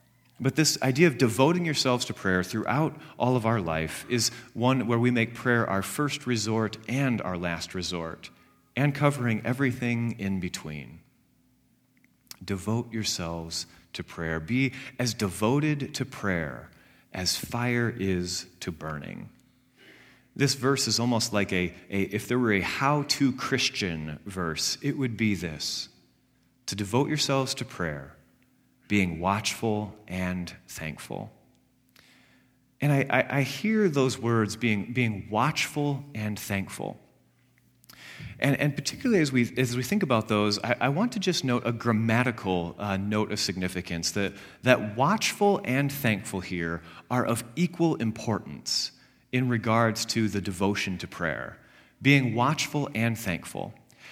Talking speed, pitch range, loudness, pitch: 140 wpm, 95-130 Hz, -27 LUFS, 115 Hz